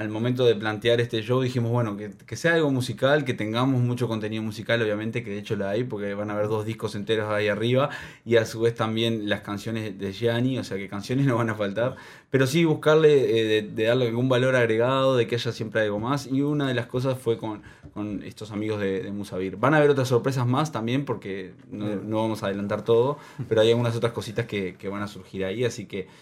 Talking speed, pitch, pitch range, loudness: 245 wpm, 115 Hz, 105-125 Hz, -25 LUFS